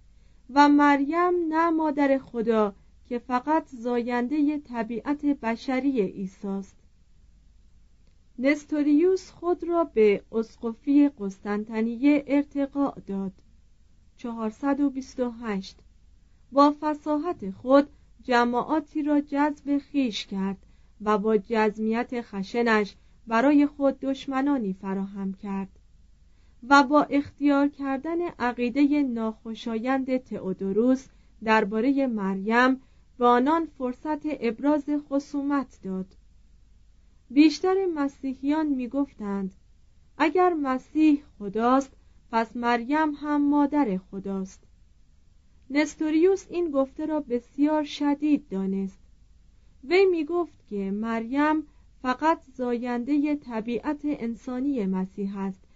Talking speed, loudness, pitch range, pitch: 90 wpm, -25 LUFS, 205-290 Hz, 255 Hz